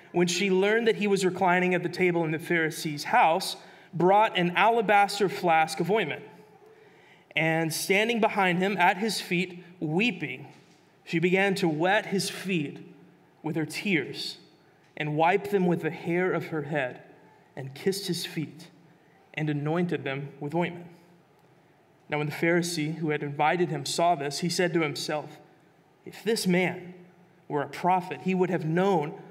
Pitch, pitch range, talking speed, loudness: 175 Hz, 155-190 Hz, 160 wpm, -26 LUFS